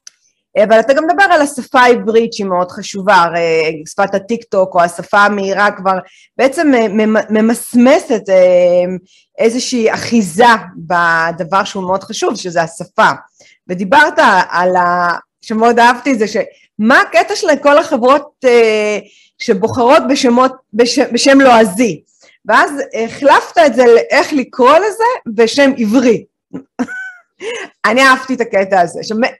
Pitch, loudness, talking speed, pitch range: 230 Hz, -11 LUFS, 120 wpm, 195-270 Hz